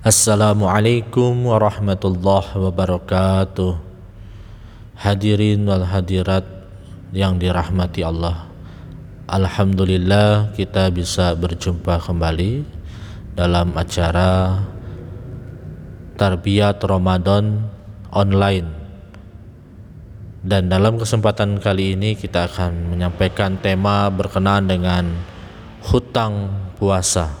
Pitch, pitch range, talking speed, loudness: 95 Hz, 90-105 Hz, 70 wpm, -18 LUFS